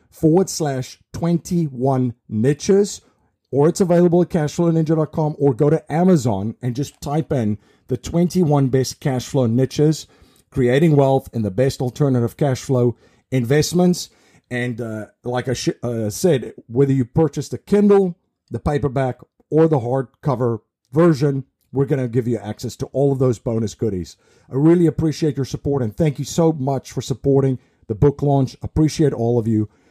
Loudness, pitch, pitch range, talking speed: -19 LUFS, 135 Hz, 125-155 Hz, 165 wpm